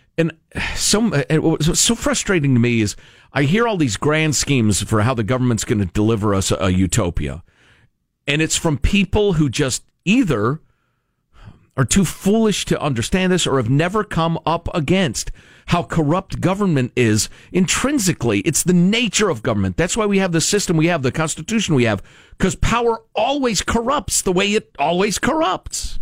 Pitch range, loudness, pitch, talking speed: 120-190 Hz, -18 LUFS, 160 Hz, 170 wpm